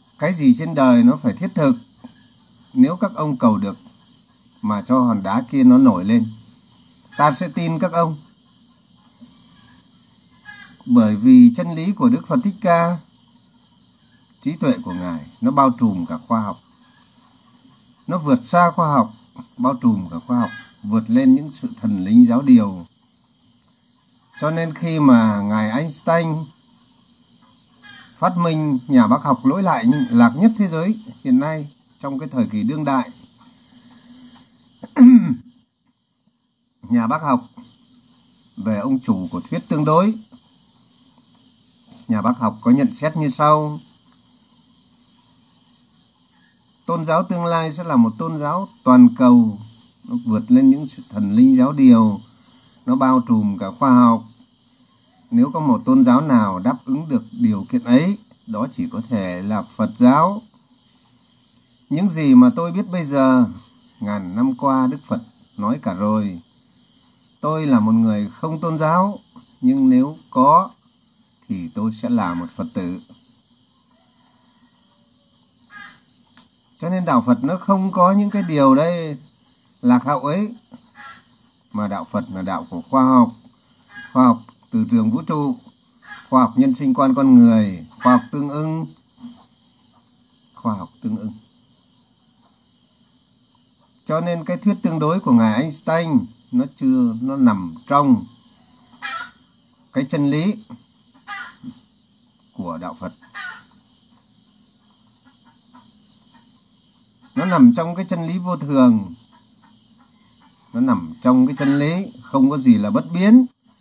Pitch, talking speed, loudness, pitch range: 220 Hz, 140 wpm, -17 LUFS, 155-245 Hz